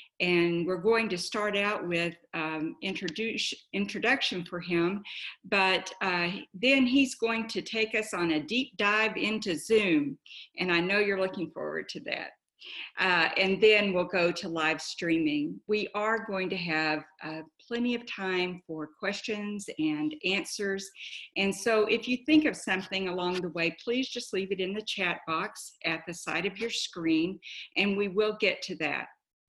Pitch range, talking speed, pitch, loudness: 175-220 Hz, 175 wpm, 195 Hz, -29 LUFS